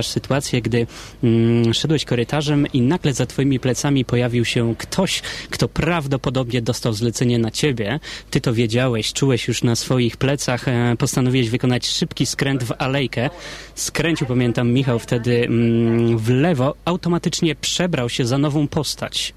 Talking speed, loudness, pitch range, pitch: 145 wpm, -19 LUFS, 120-145 Hz, 125 Hz